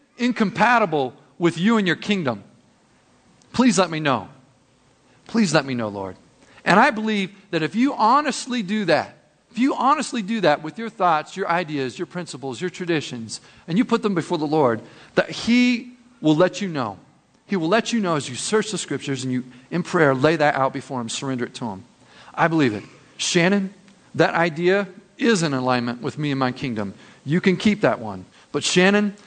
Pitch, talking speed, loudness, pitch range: 170 Hz, 195 wpm, -21 LUFS, 135-210 Hz